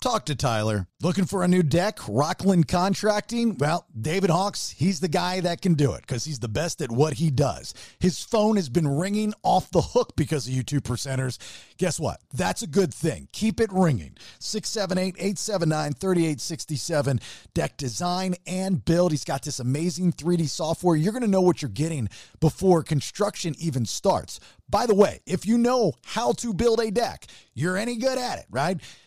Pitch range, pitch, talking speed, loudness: 150-195 Hz, 175 Hz, 185 wpm, -25 LUFS